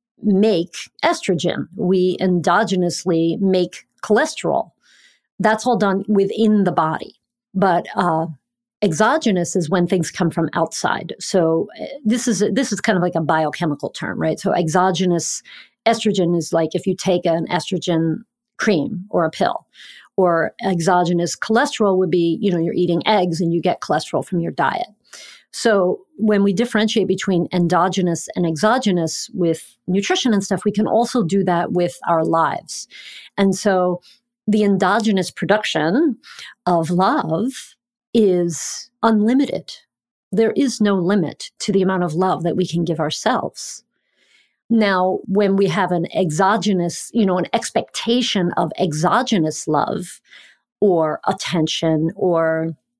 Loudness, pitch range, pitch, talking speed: -19 LUFS, 170-215 Hz, 185 Hz, 140 wpm